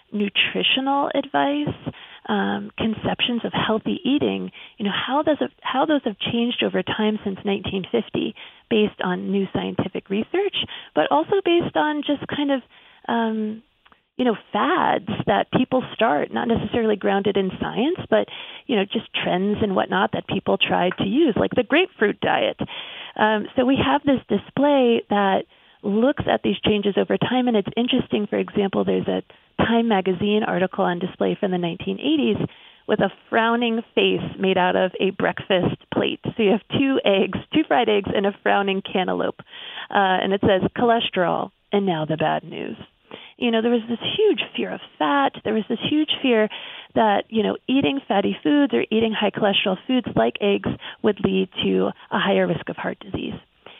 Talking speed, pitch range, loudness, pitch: 175 wpm, 195-245 Hz, -22 LUFS, 215 Hz